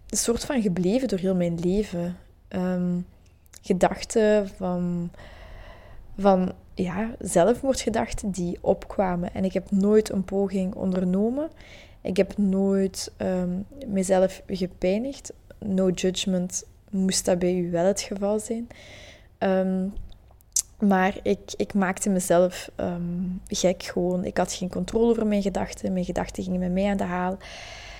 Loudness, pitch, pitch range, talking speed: -25 LUFS, 190 Hz, 180-200 Hz, 130 wpm